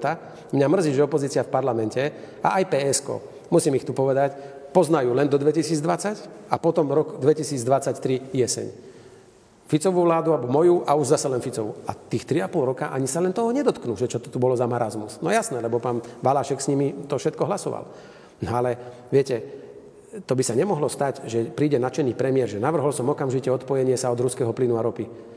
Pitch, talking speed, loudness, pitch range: 135 Hz, 190 wpm, -23 LUFS, 125-155 Hz